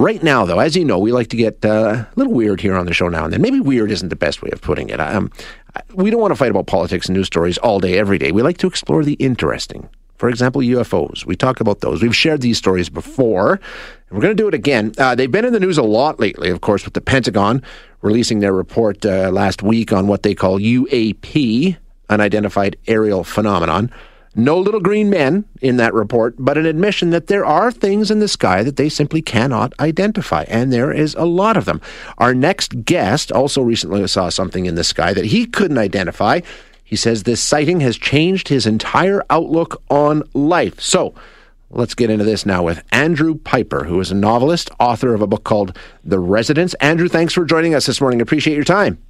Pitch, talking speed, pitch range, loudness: 120 Hz, 225 wpm, 105-160 Hz, -15 LUFS